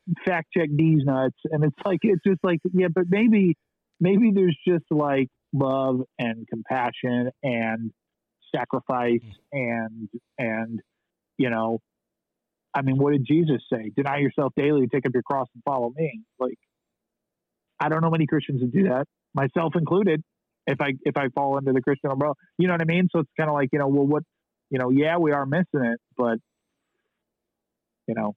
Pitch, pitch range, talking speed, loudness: 140 Hz, 125-165 Hz, 180 wpm, -24 LUFS